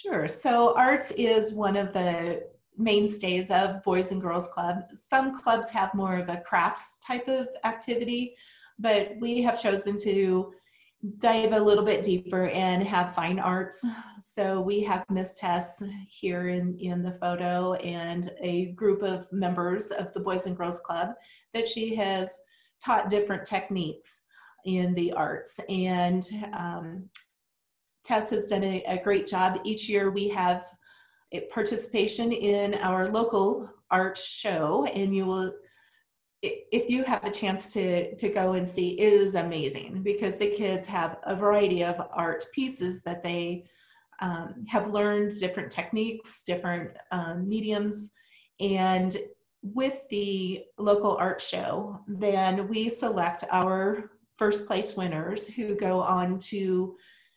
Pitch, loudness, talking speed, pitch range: 195 Hz, -28 LUFS, 145 wpm, 180-215 Hz